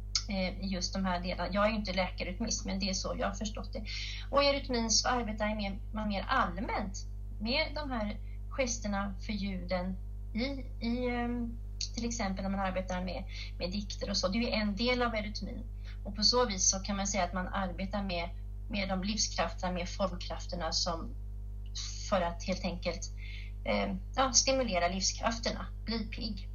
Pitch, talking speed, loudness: 185 Hz, 165 wpm, -33 LUFS